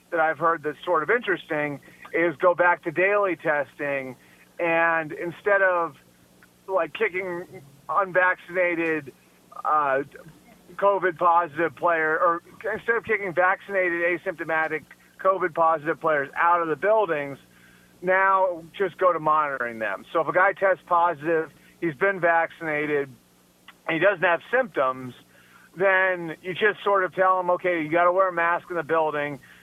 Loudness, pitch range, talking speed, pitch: -23 LUFS, 155-185 Hz, 150 wpm, 170 Hz